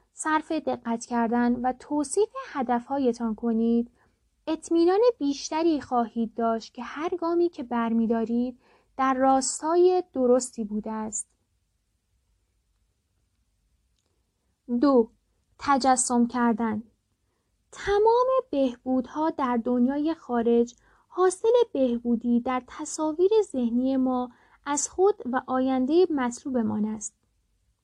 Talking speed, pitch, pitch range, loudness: 90 wpm, 250 Hz, 230-305 Hz, -25 LUFS